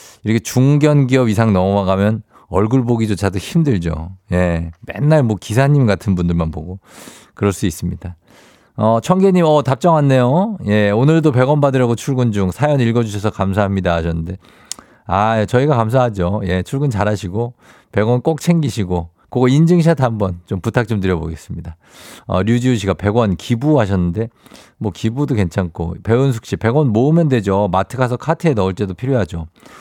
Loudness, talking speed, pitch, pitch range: -16 LUFS, 335 characters per minute, 110 Hz, 95-130 Hz